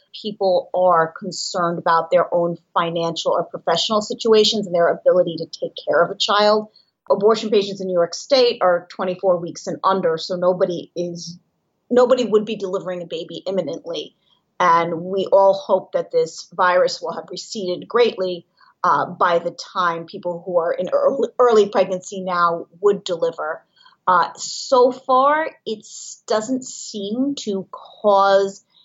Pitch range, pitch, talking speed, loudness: 175-220 Hz, 190 Hz, 150 wpm, -19 LUFS